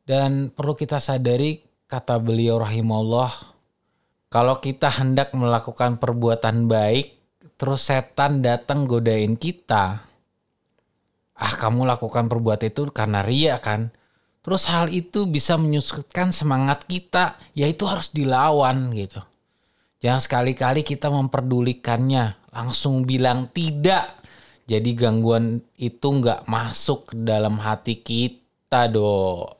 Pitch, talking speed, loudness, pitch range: 125 Hz, 105 wpm, -22 LUFS, 115-145 Hz